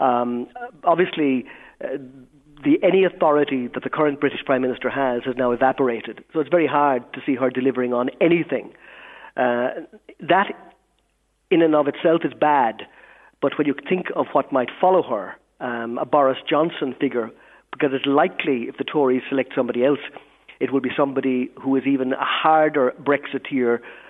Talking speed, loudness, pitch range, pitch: 165 wpm, -21 LUFS, 125-150 Hz, 135 Hz